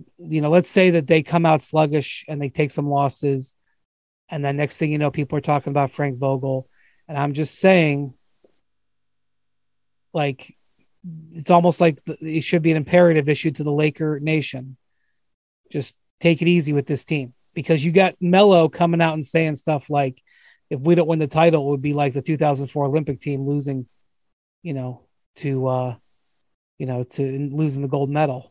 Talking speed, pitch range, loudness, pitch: 185 wpm, 140-160 Hz, -20 LUFS, 150 Hz